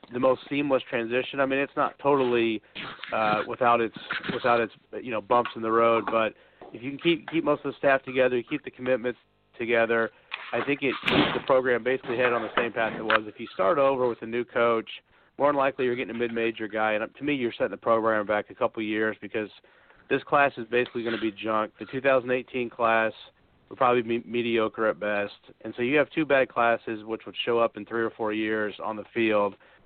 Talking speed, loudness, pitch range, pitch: 235 wpm, -26 LUFS, 110-130 Hz, 120 Hz